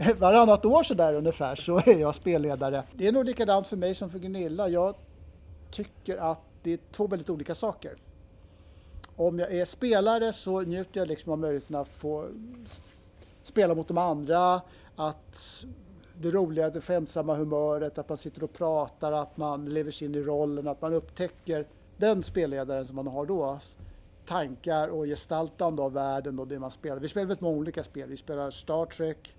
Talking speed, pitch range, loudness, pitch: 180 wpm, 140-180 Hz, -28 LUFS, 155 Hz